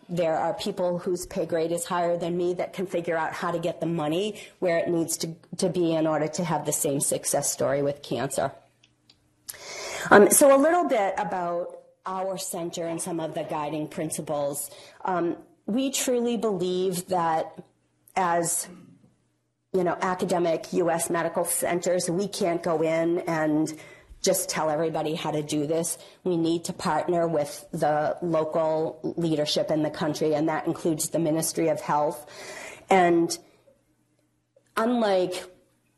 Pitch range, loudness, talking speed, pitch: 155-185 Hz, -26 LUFS, 160 wpm, 170 Hz